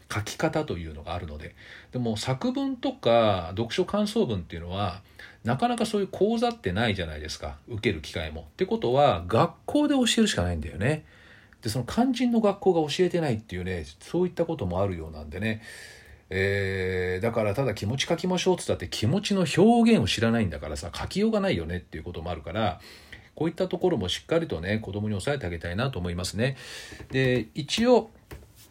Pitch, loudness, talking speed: 115 Hz, -27 LUFS, 430 characters per minute